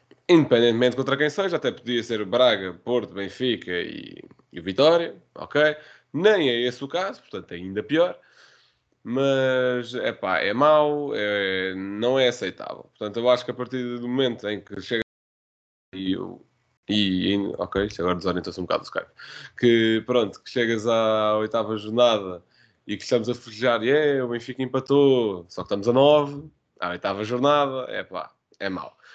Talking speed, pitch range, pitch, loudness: 165 wpm, 105-130 Hz, 120 Hz, -23 LUFS